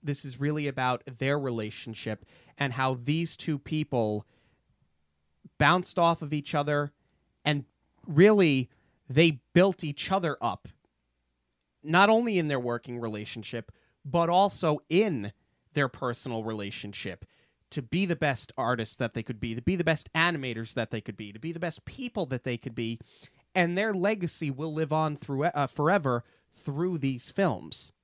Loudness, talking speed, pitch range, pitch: -28 LUFS, 160 wpm, 115-160 Hz, 140 Hz